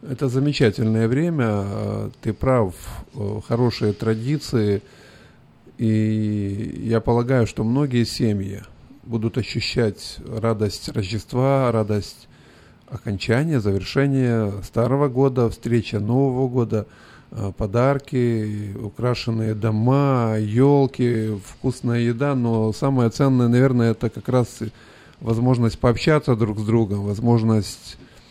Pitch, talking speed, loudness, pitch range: 115 Hz, 95 wpm, -21 LUFS, 110-125 Hz